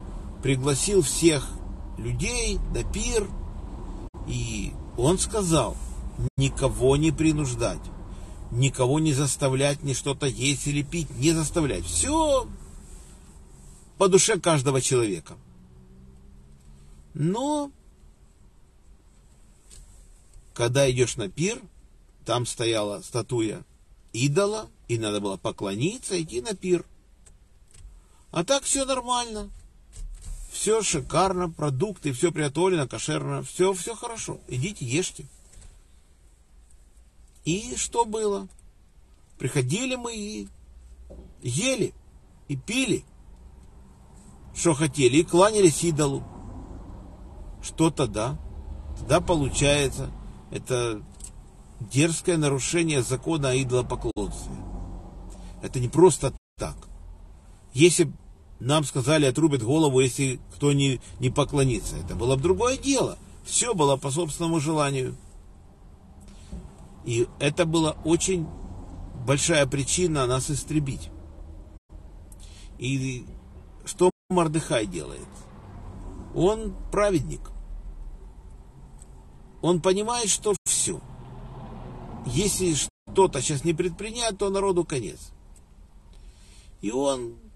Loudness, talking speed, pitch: -25 LUFS, 90 wpm, 130 Hz